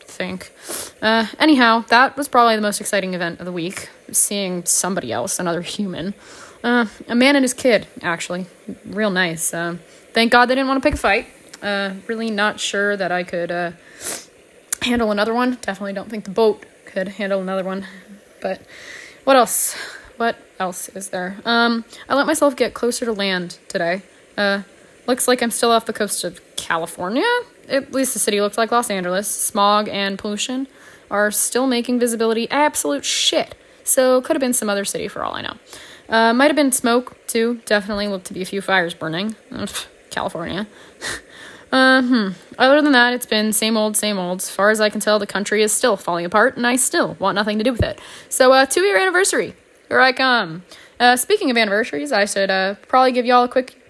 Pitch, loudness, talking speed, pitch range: 220 Hz, -18 LUFS, 200 wpm, 195-255 Hz